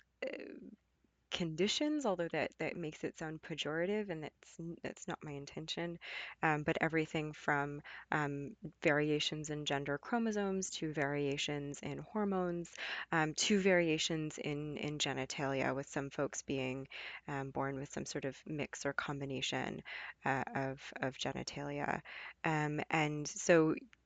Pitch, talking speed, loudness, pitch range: 150 Hz, 130 wpm, -38 LUFS, 140-165 Hz